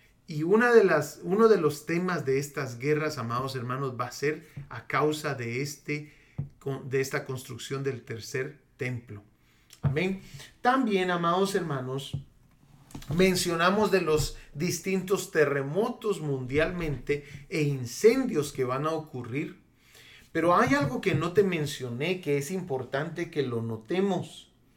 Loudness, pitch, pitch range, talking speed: -28 LUFS, 150 Hz, 130-175 Hz, 135 wpm